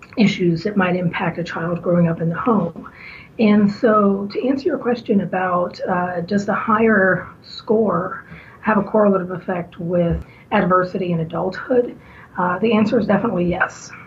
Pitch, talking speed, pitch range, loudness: 190 Hz, 160 wpm, 175-215 Hz, -19 LUFS